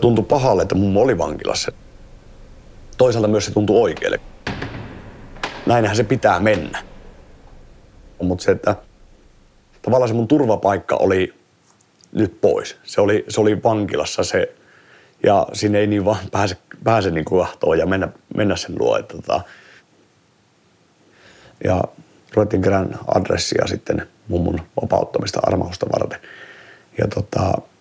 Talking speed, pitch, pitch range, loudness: 120 wpm, 105 Hz, 95-115 Hz, -19 LUFS